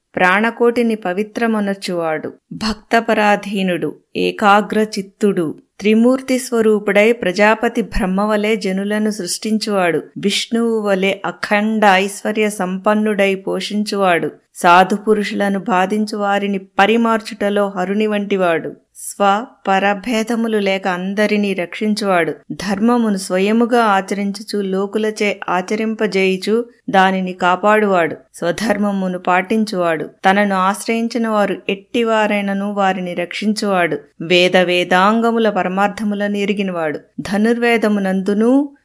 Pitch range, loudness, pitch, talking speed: 190-220 Hz, -16 LUFS, 205 Hz, 75 wpm